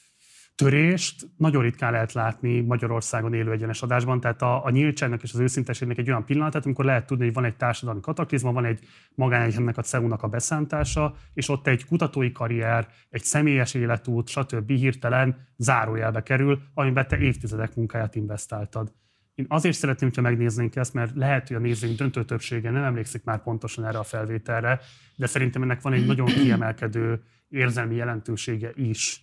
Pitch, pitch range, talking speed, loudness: 120 Hz, 115-135 Hz, 165 wpm, -25 LUFS